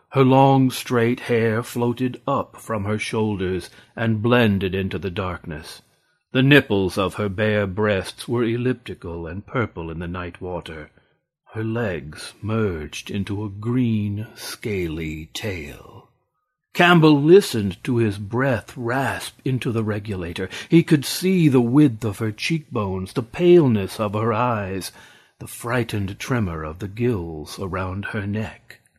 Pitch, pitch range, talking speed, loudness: 110 Hz, 95-125 Hz, 140 wpm, -21 LUFS